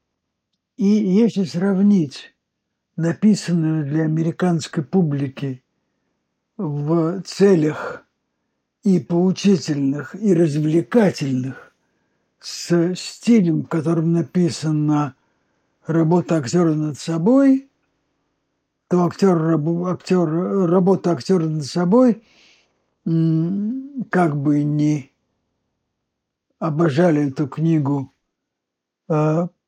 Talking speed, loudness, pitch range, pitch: 70 wpm, -19 LUFS, 155-185 Hz, 170 Hz